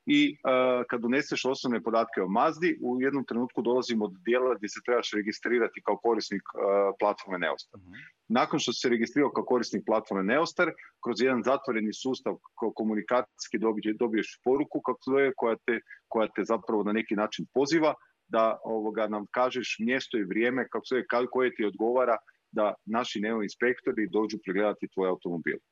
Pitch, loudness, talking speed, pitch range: 115 Hz, -29 LUFS, 165 wpm, 105-125 Hz